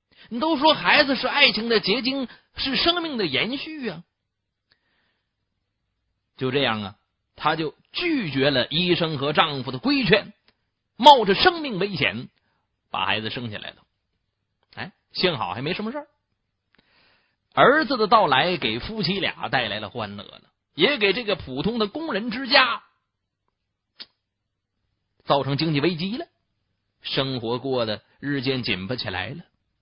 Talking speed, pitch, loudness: 205 characters per minute, 155 Hz, -22 LUFS